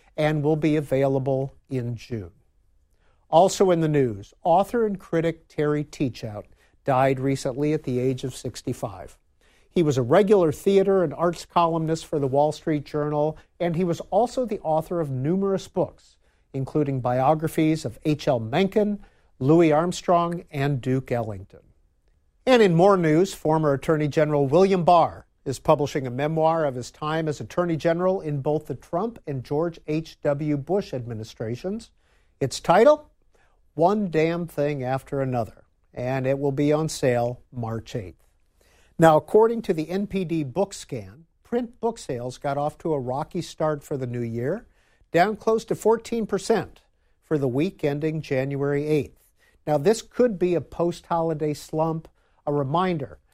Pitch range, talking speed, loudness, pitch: 130-175 Hz, 155 wpm, -24 LUFS, 150 Hz